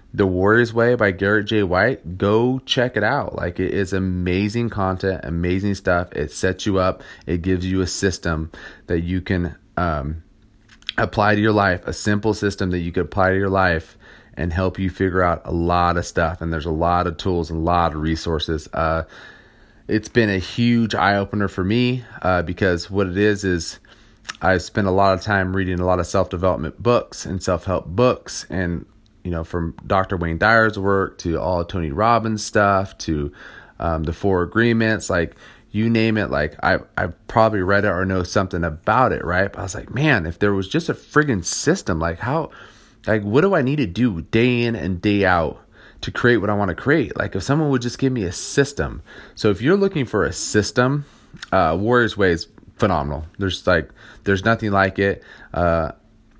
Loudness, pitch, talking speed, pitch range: -20 LUFS, 95 Hz, 205 wpm, 85-110 Hz